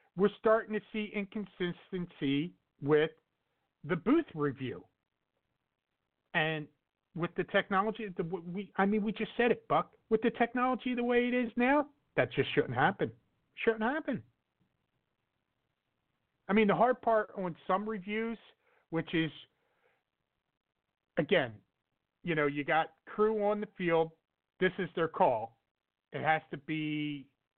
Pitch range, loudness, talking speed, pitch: 160-225 Hz, -32 LUFS, 135 wpm, 195 Hz